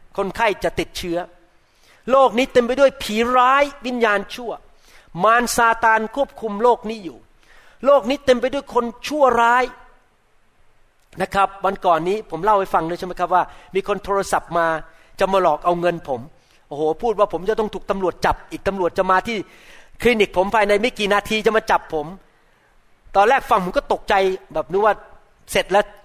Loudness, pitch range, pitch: -19 LUFS, 180-240 Hz, 205 Hz